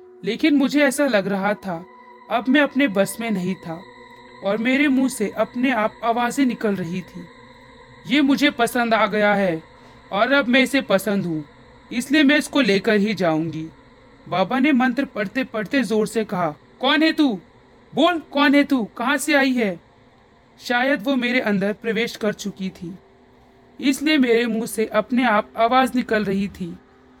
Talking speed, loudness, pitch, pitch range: 170 wpm, -20 LUFS, 230 Hz, 195-265 Hz